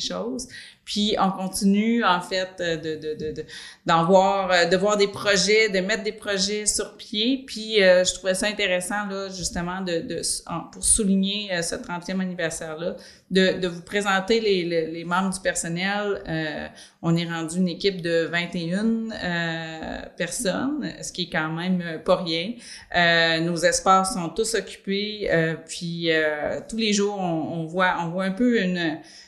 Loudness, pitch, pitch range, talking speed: -23 LUFS, 185 Hz, 170-205 Hz, 170 wpm